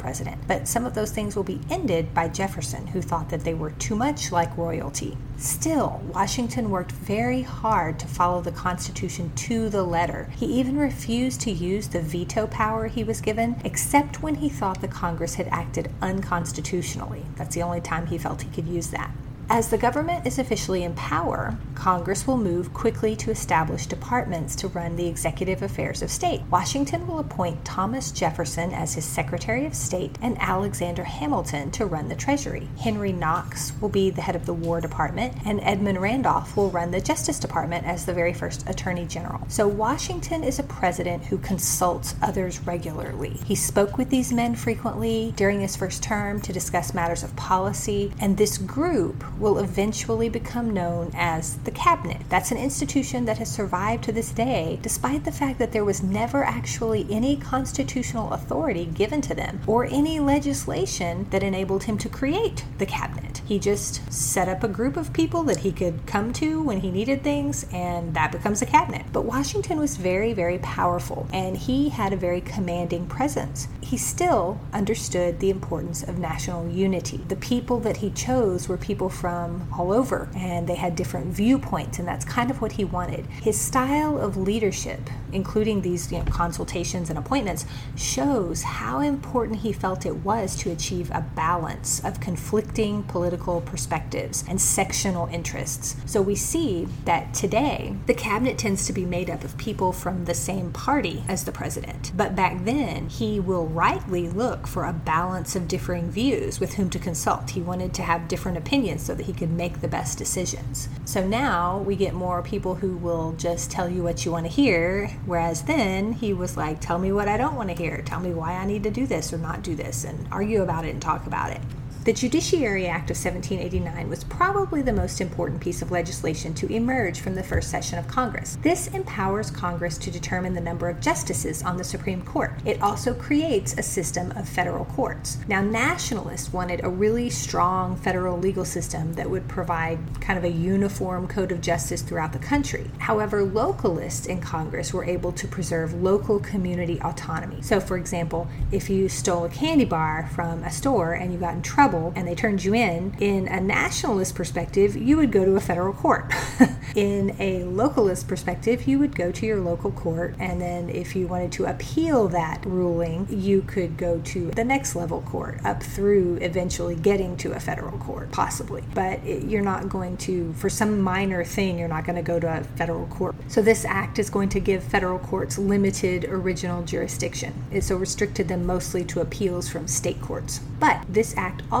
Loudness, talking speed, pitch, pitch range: -25 LUFS, 190 wpm, 175 Hz, 145-195 Hz